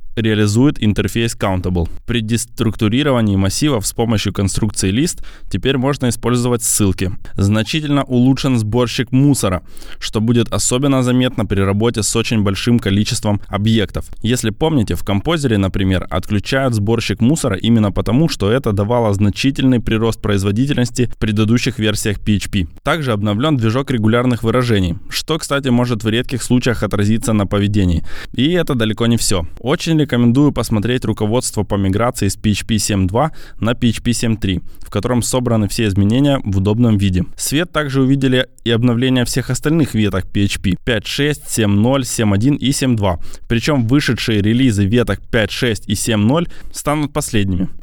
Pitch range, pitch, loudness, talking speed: 100-130 Hz, 115 Hz, -16 LUFS, 140 wpm